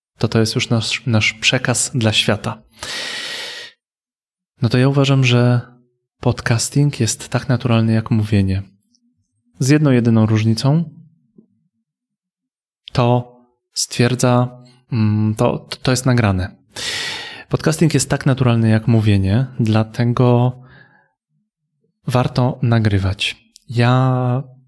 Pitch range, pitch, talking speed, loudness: 115-145 Hz, 125 Hz, 95 wpm, -17 LUFS